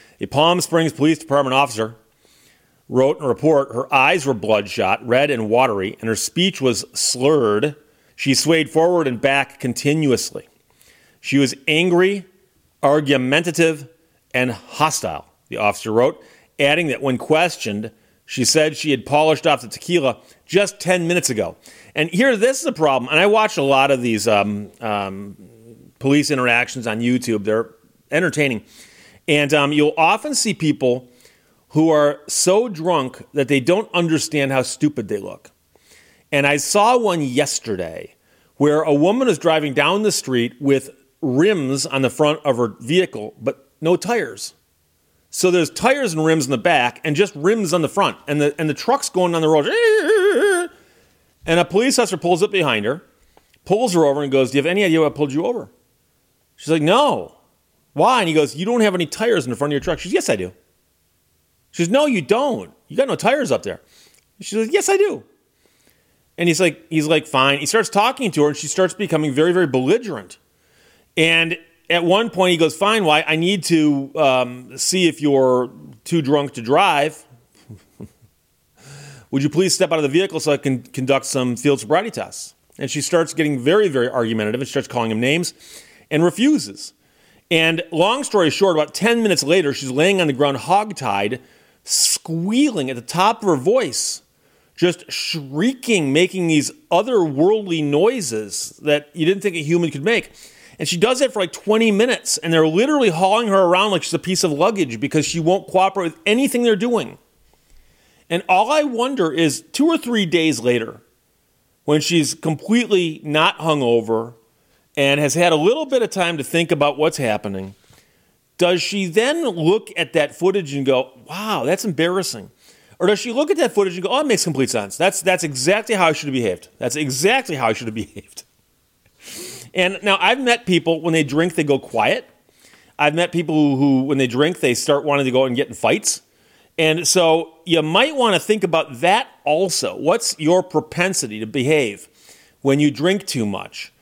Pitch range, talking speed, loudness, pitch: 135-185 Hz, 185 wpm, -18 LUFS, 155 Hz